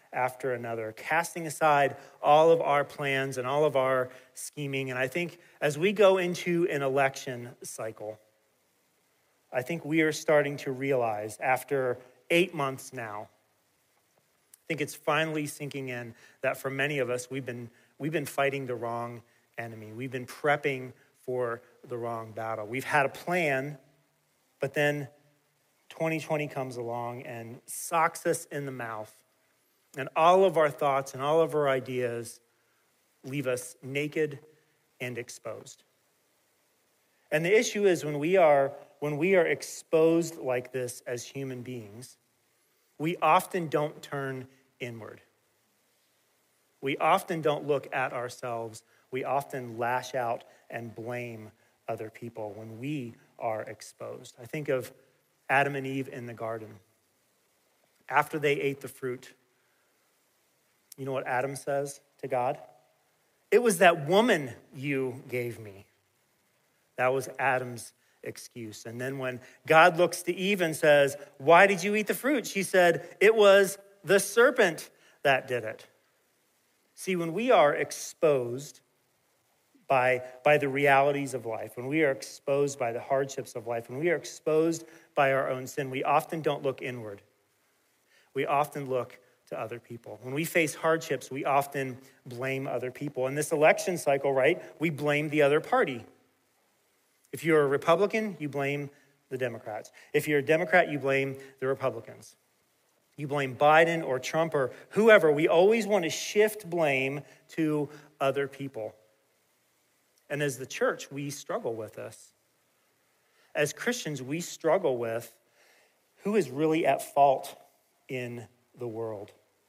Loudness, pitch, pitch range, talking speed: -28 LUFS, 140 Hz, 125-155 Hz, 150 wpm